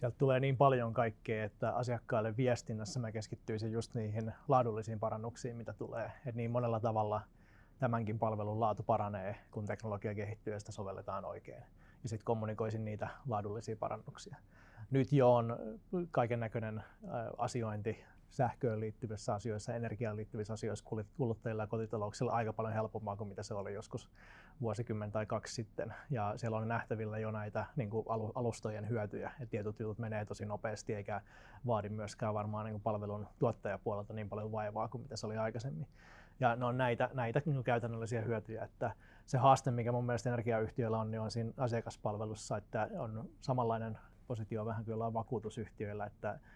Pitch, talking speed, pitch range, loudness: 110 Hz, 160 wpm, 110-120 Hz, -38 LUFS